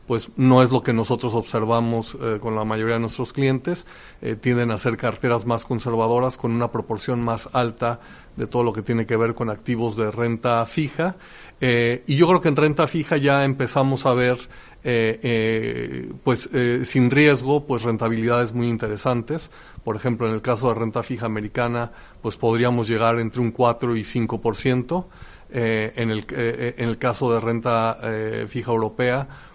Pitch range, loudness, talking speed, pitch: 115-125 Hz, -22 LUFS, 180 wpm, 120 Hz